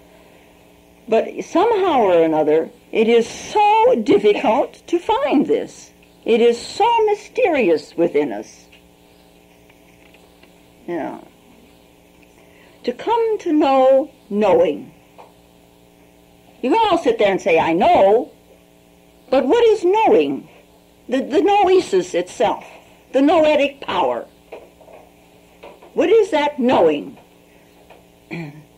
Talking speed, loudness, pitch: 100 wpm, -17 LUFS, 170 Hz